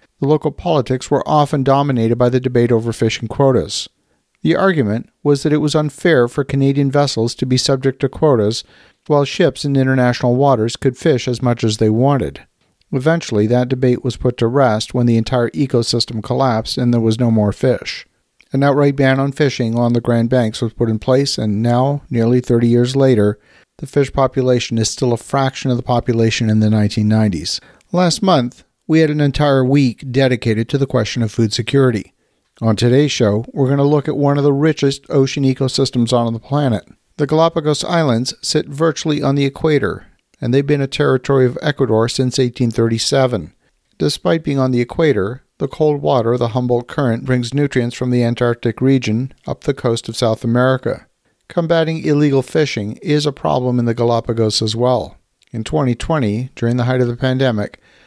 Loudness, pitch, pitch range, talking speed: -16 LUFS, 130 Hz, 120-140 Hz, 185 wpm